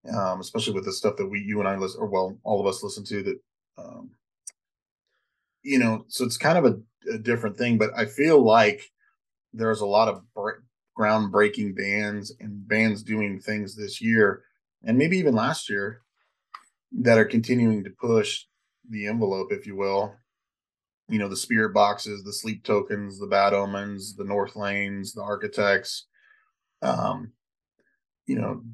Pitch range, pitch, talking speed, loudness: 100-115 Hz, 105 Hz, 170 wpm, -25 LUFS